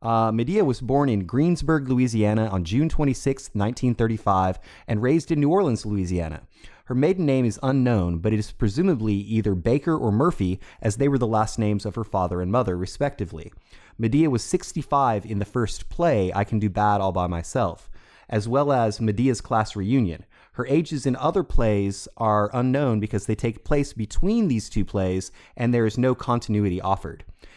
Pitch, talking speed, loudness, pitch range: 110 Hz, 190 wpm, -23 LUFS, 100-130 Hz